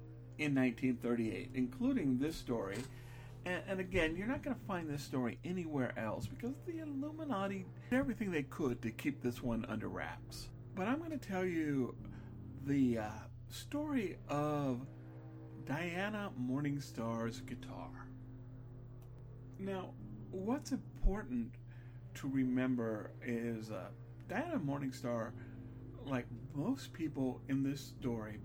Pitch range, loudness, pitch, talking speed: 120-145 Hz, -40 LUFS, 125 Hz, 120 wpm